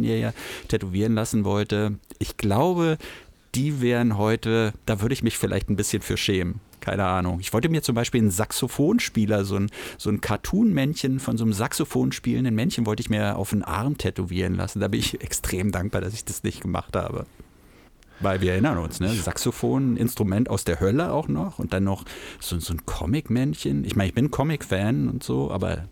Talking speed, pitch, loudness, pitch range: 200 wpm, 105 Hz, -25 LUFS, 95-120 Hz